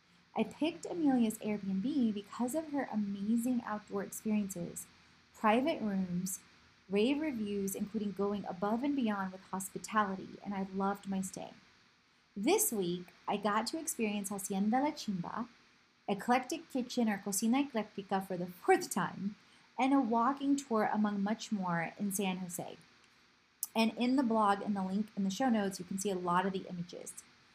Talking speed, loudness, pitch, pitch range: 160 wpm, -35 LUFS, 210 Hz, 195-240 Hz